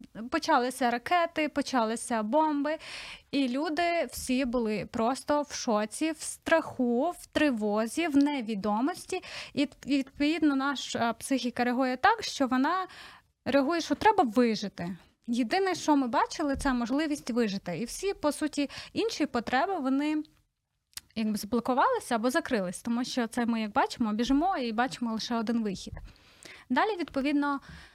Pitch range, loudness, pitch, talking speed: 235-305 Hz, -29 LUFS, 270 Hz, 130 wpm